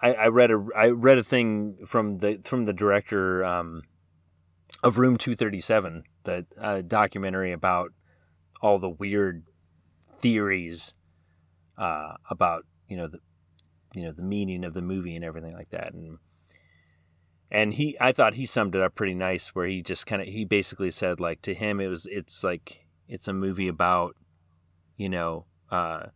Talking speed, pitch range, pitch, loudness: 170 wpm, 85-105 Hz, 95 Hz, -26 LUFS